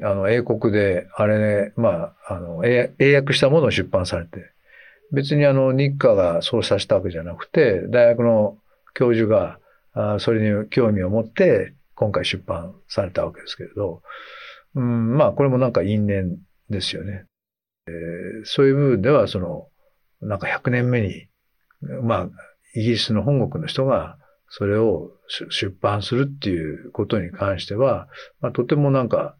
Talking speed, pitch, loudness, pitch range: 295 characters per minute, 115 Hz, -20 LUFS, 100-130 Hz